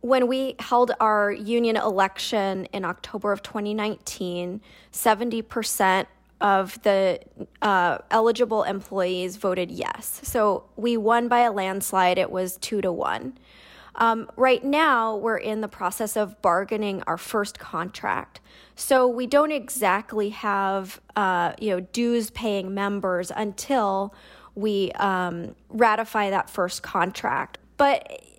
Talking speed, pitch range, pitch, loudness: 125 wpm, 190-230 Hz, 210 Hz, -24 LUFS